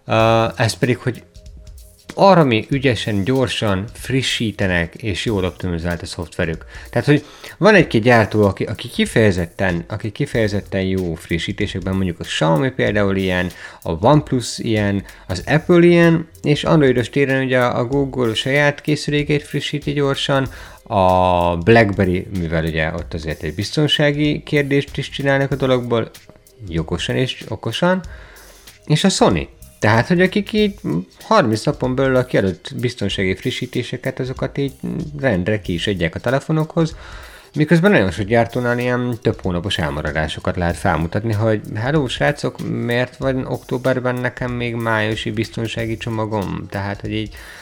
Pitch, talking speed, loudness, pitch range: 115 Hz, 140 wpm, -18 LUFS, 95-135 Hz